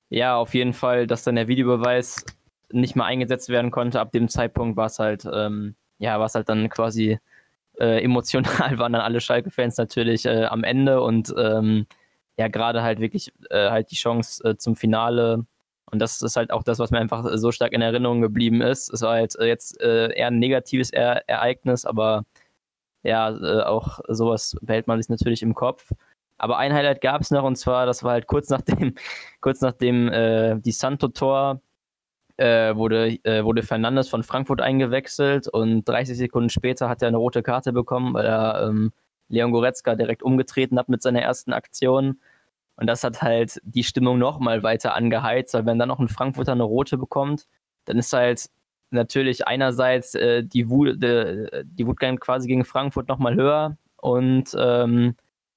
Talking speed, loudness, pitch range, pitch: 185 wpm, -22 LUFS, 115-130 Hz, 120 Hz